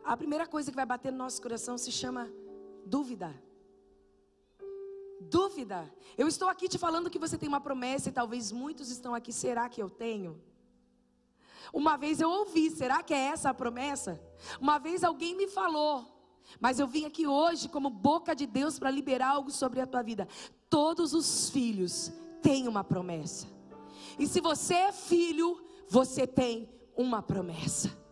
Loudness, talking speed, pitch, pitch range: -32 LUFS, 165 wpm, 270 Hz, 235-320 Hz